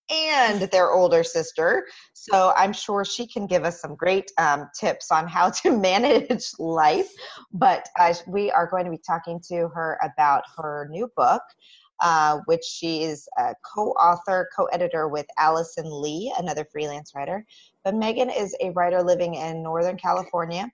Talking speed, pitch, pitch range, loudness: 170 wpm, 180 Hz, 160-220 Hz, -23 LUFS